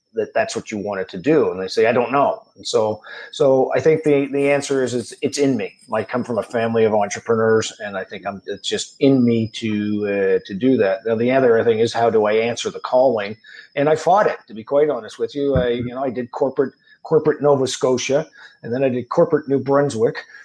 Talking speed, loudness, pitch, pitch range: 245 wpm, -19 LUFS, 130 Hz, 115-145 Hz